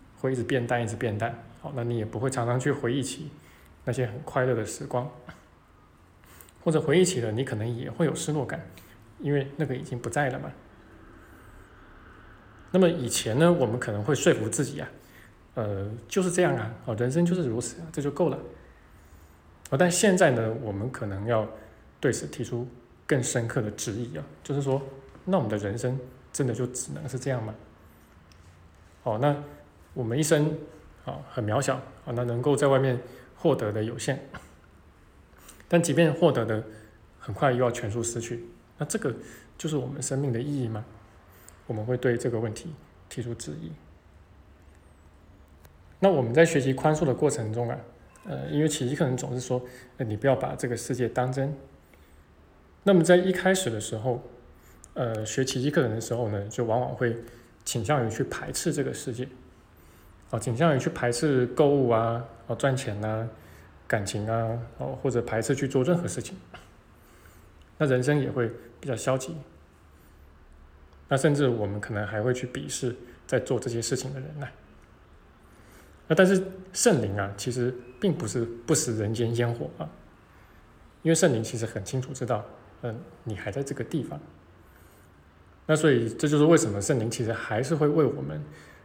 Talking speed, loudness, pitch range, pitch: 250 characters per minute, -27 LUFS, 105-135 Hz, 120 Hz